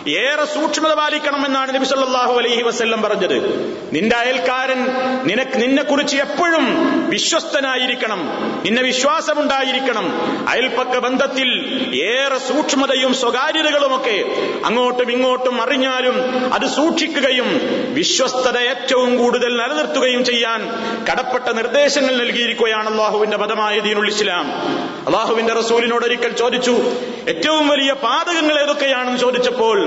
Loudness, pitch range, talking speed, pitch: -16 LUFS, 240-290 Hz, 90 wpm, 260 Hz